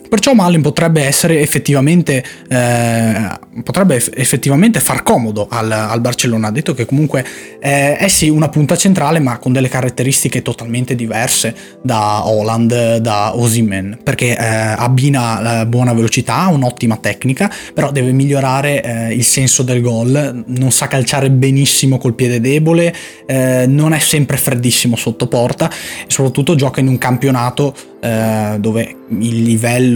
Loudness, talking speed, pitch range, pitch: -13 LUFS, 150 wpm, 115-145 Hz, 130 Hz